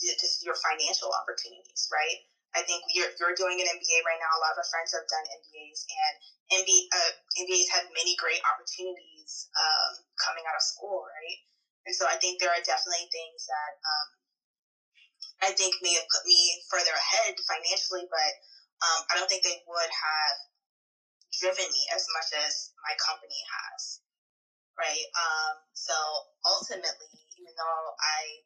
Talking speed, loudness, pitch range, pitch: 165 wpm, -27 LUFS, 155-185 Hz, 175 Hz